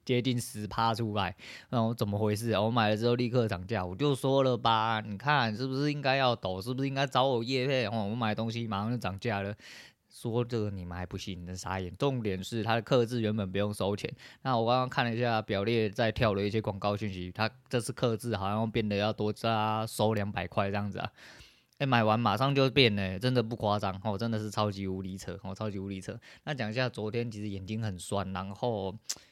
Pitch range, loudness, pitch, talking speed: 100-120 Hz, -31 LUFS, 110 Hz, 340 characters per minute